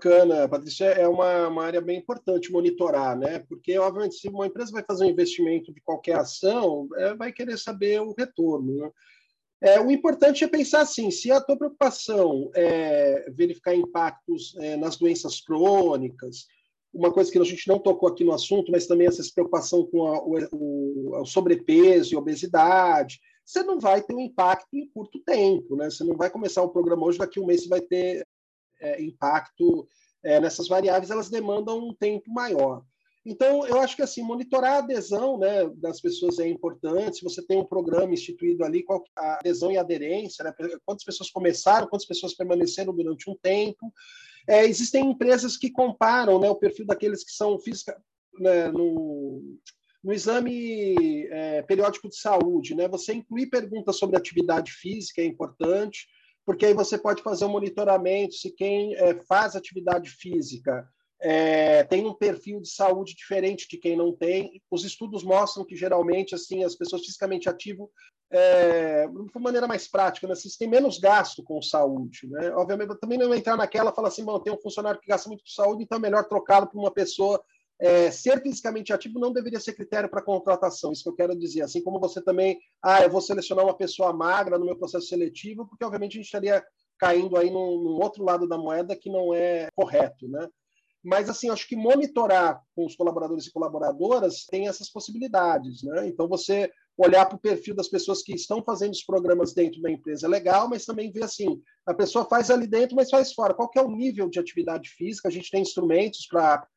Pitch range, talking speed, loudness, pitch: 175-225 Hz, 190 wpm, -24 LUFS, 195 Hz